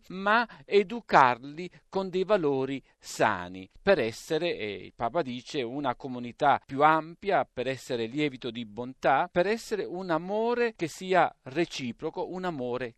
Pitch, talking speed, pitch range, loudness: 155 Hz, 140 wpm, 125-185 Hz, -28 LUFS